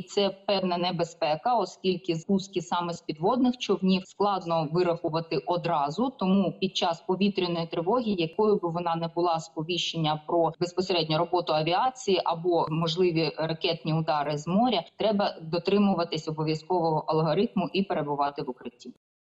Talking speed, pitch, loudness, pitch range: 130 wpm, 175 Hz, -27 LUFS, 165-190 Hz